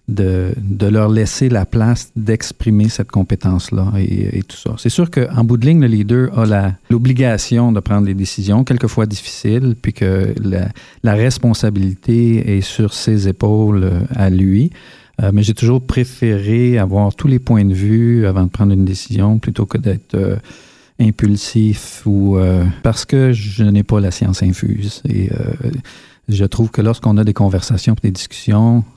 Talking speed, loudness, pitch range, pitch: 175 wpm, -15 LUFS, 100-120 Hz, 110 Hz